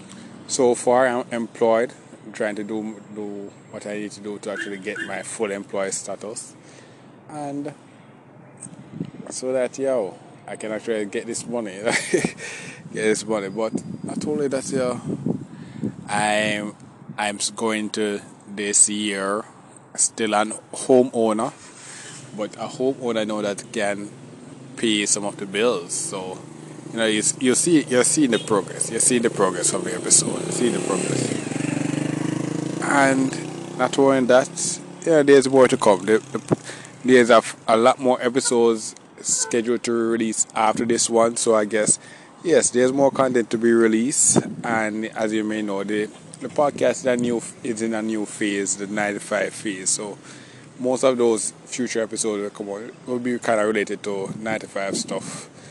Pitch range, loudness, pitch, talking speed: 105-130 Hz, -21 LUFS, 115 Hz, 160 wpm